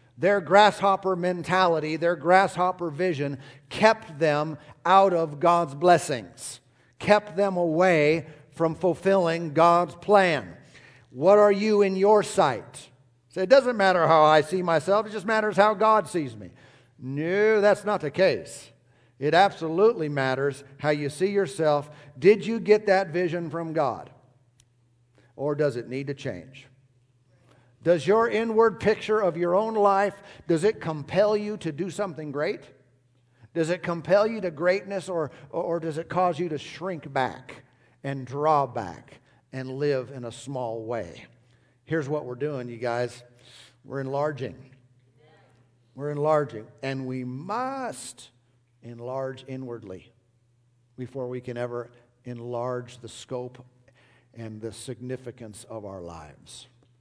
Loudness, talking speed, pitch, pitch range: -24 LUFS, 140 wpm, 145 Hz, 125-180 Hz